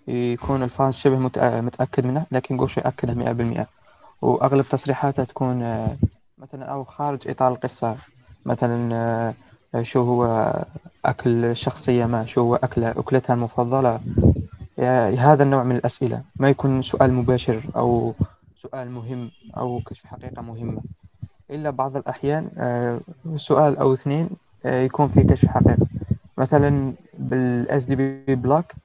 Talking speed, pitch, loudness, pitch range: 120 wpm, 125 Hz, -22 LUFS, 120-135 Hz